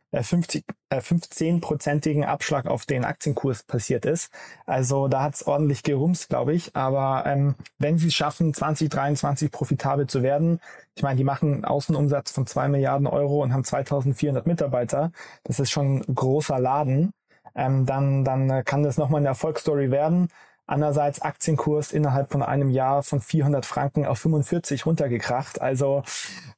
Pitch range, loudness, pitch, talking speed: 135-150 Hz, -23 LUFS, 145 Hz, 155 wpm